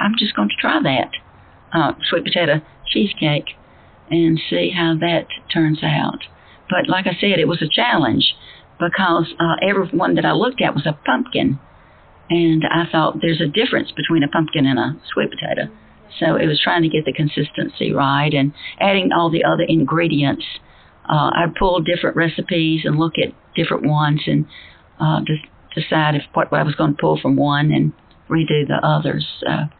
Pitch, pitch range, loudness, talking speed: 160 Hz, 150-170 Hz, -18 LUFS, 185 wpm